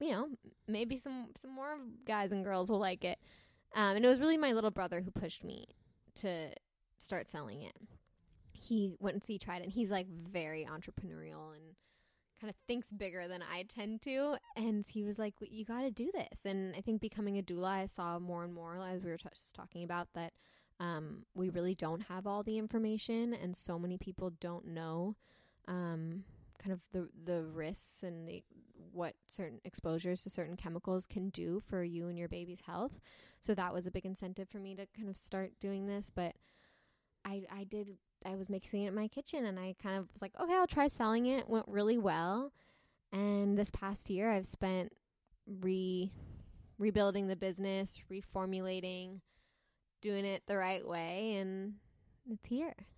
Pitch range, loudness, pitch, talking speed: 180-215 Hz, -40 LUFS, 195 Hz, 190 wpm